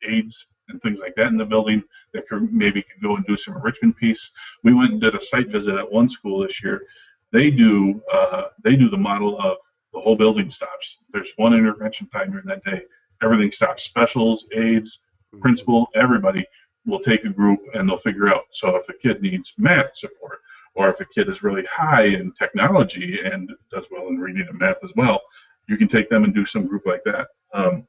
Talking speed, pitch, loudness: 215 wpm, 185 Hz, -20 LUFS